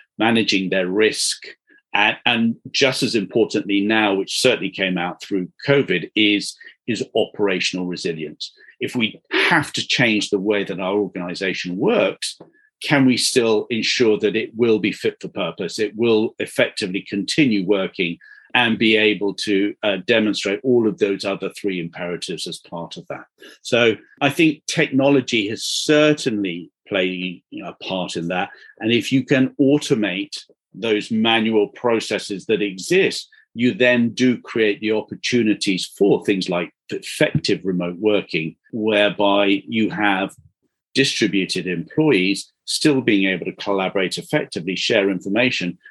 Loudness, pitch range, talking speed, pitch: -19 LUFS, 95-125 Hz, 140 wpm, 105 Hz